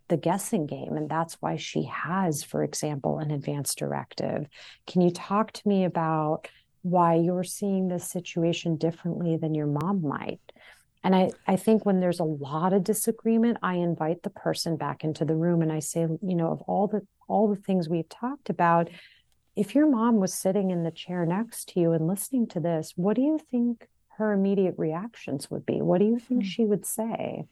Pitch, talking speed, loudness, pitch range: 180 Hz, 200 wpm, -27 LUFS, 165-205 Hz